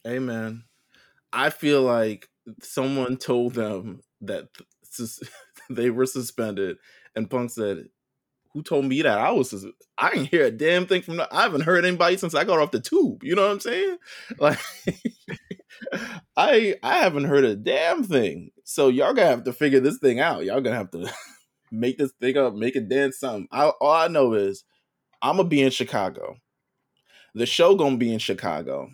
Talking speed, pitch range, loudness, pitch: 185 wpm, 120-175 Hz, -23 LUFS, 130 Hz